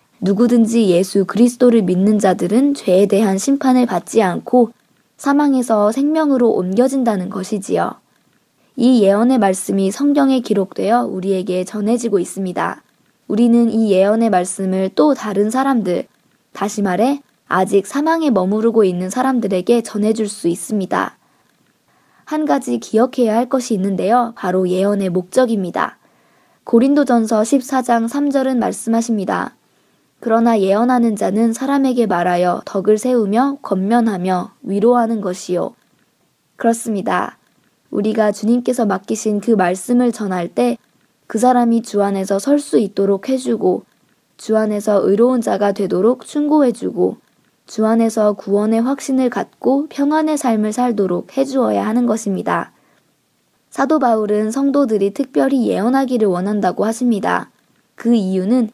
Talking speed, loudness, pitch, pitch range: 305 characters per minute, -16 LUFS, 225 Hz, 195-250 Hz